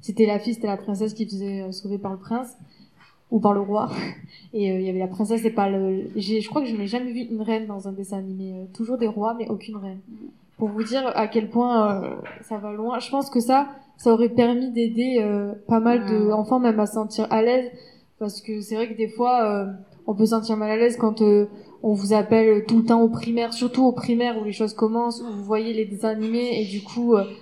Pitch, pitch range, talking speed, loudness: 220 Hz, 210-235 Hz, 255 wpm, -23 LUFS